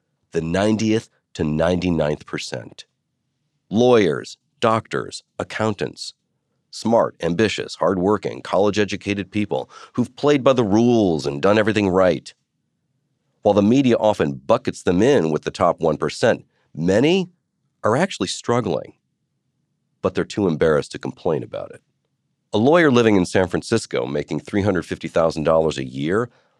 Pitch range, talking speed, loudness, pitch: 85-125 Hz, 125 wpm, -20 LUFS, 105 Hz